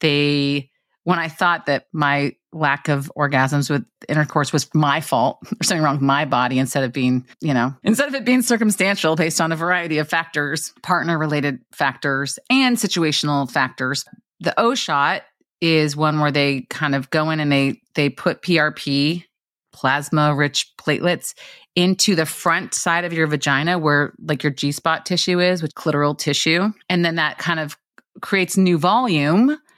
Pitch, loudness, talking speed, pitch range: 155 Hz, -19 LUFS, 175 wpm, 145-175 Hz